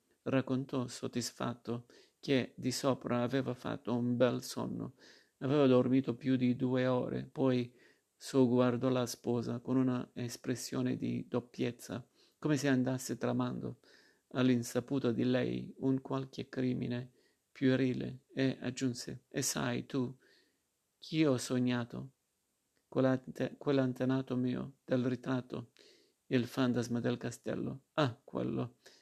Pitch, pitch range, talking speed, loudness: 125 Hz, 120-130 Hz, 115 wpm, -35 LUFS